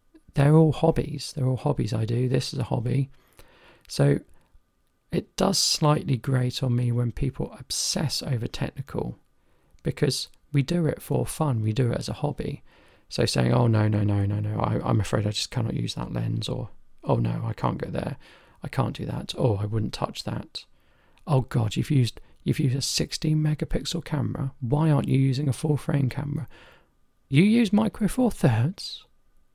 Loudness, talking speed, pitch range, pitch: -26 LUFS, 185 wpm, 115-150 Hz, 135 Hz